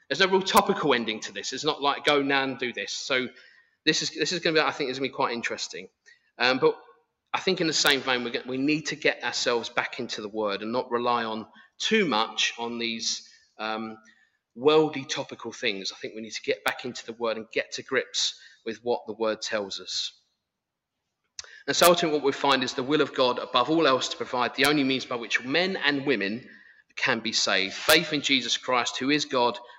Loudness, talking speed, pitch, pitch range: -25 LUFS, 230 wpm, 130 Hz, 115-150 Hz